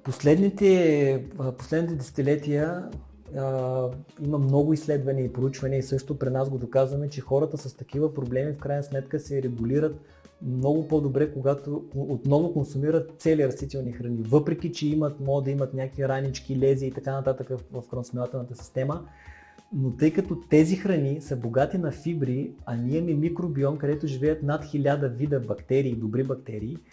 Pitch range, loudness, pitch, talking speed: 130-150 Hz, -26 LUFS, 140 Hz, 150 wpm